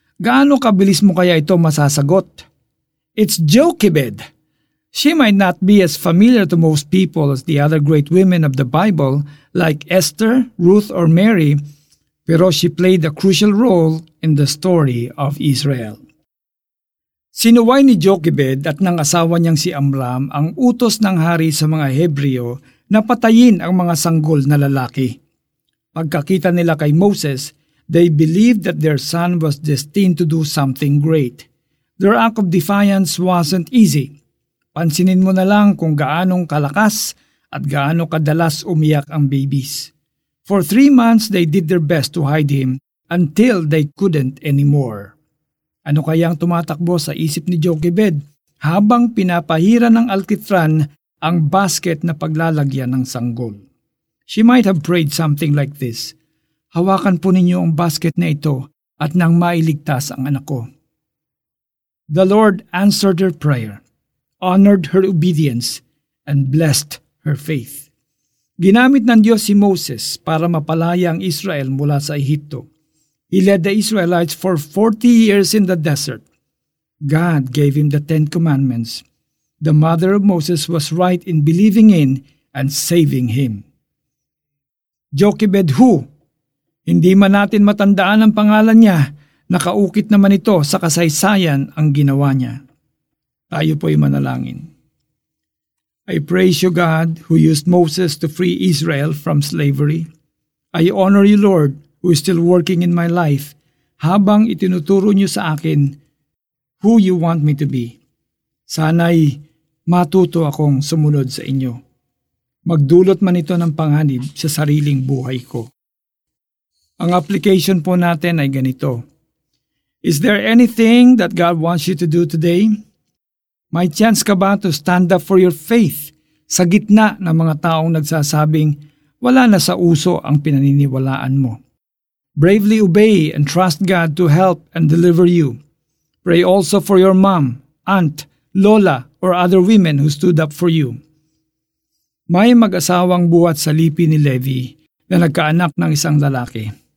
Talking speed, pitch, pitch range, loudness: 140 wpm, 165 Hz, 145-185 Hz, -14 LUFS